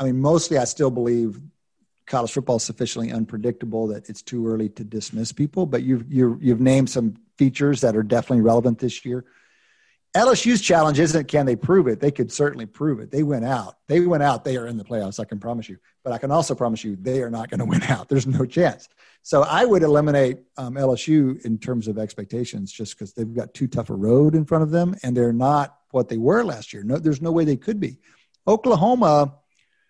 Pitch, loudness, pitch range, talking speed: 130 Hz, -21 LUFS, 115-150 Hz, 225 wpm